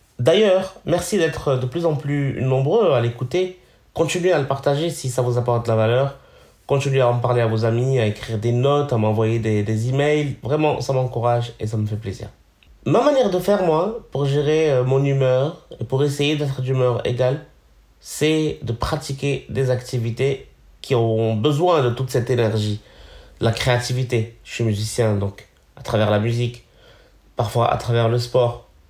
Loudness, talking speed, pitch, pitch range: -20 LUFS, 180 wpm, 125 Hz, 115-140 Hz